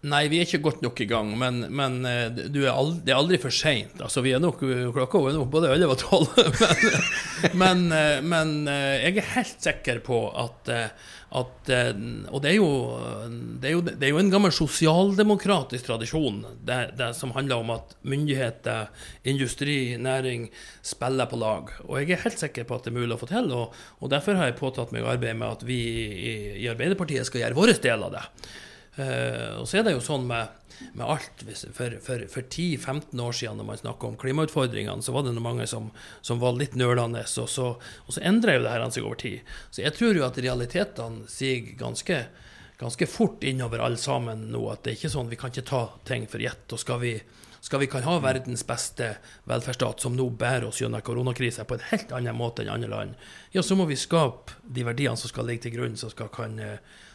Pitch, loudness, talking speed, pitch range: 125 Hz, -26 LUFS, 210 wpm, 115-145 Hz